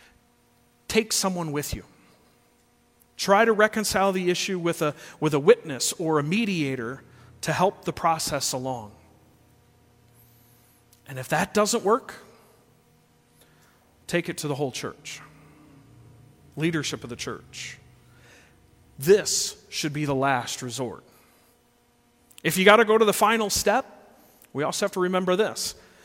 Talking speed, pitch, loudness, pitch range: 135 wpm, 155 Hz, -24 LUFS, 130-195 Hz